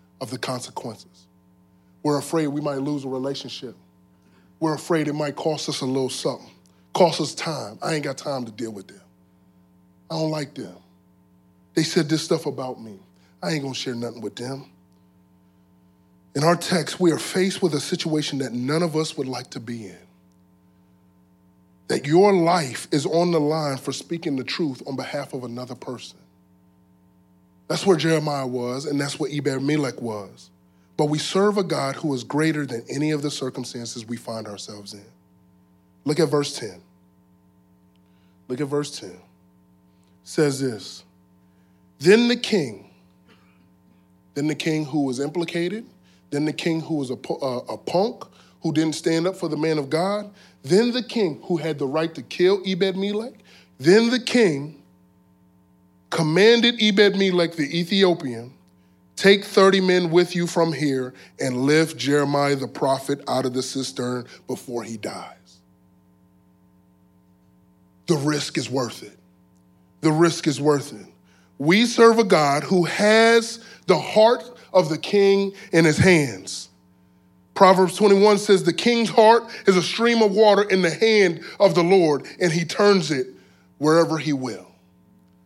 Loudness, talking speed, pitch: -21 LUFS, 165 wpm, 140 Hz